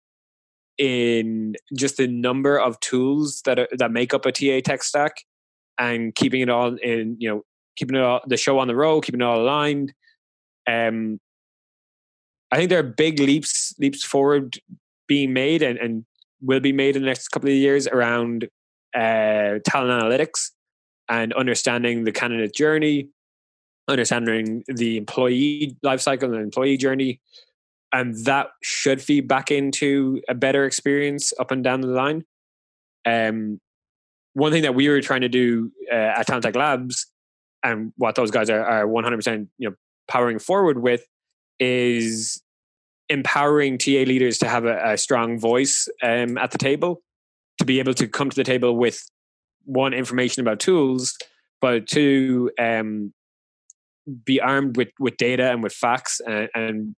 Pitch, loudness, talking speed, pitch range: 125 Hz, -21 LUFS, 160 wpm, 115-140 Hz